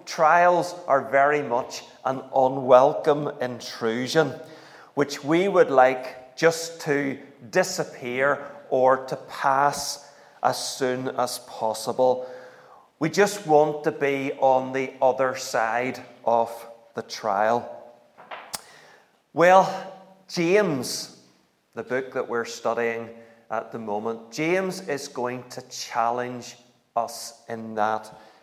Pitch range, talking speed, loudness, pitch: 120-150 Hz, 110 wpm, -24 LUFS, 130 Hz